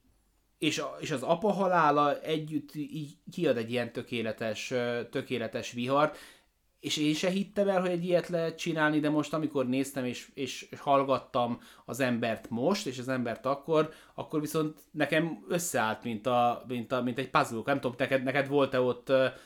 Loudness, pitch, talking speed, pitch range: -30 LUFS, 140 Hz, 165 wpm, 125-155 Hz